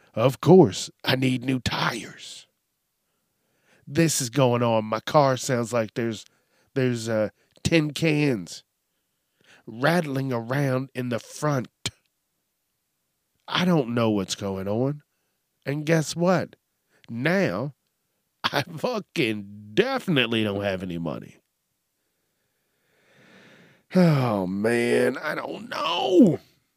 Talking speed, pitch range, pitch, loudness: 105 wpm, 110-145 Hz, 125 Hz, -24 LUFS